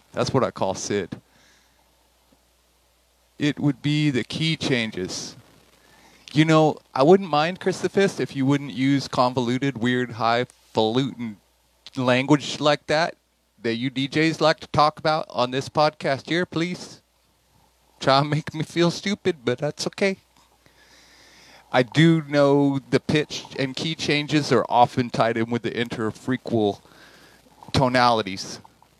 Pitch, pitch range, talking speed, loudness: 135 Hz, 120-155 Hz, 130 wpm, -22 LUFS